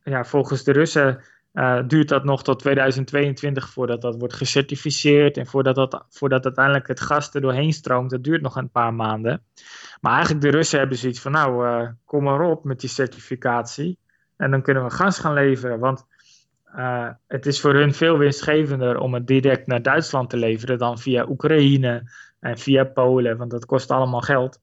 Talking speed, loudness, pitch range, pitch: 190 wpm, -20 LUFS, 125-145 Hz, 135 Hz